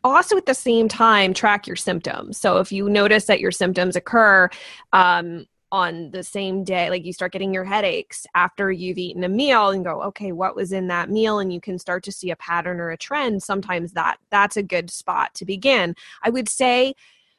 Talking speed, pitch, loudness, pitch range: 215 wpm, 195 Hz, -20 LUFS, 180-220 Hz